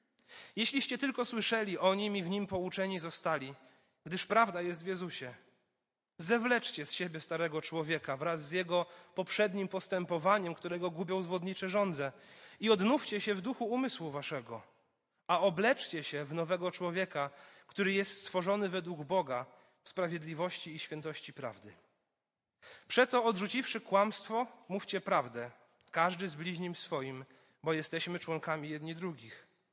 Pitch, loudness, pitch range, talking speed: 180 Hz, -35 LUFS, 160-200 Hz, 135 wpm